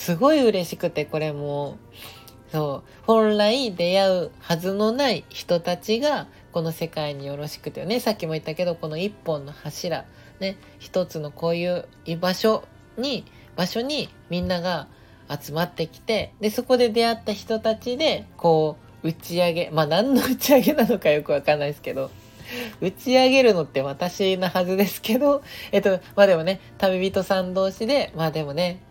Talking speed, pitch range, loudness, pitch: 330 characters per minute, 155-220 Hz, -23 LUFS, 180 Hz